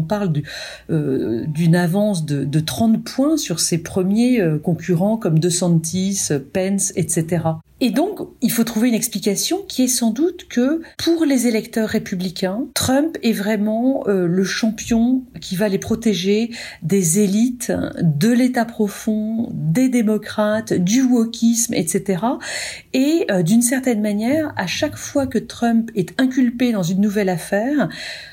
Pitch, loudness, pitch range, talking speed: 215 Hz, -19 LUFS, 185-245 Hz, 140 wpm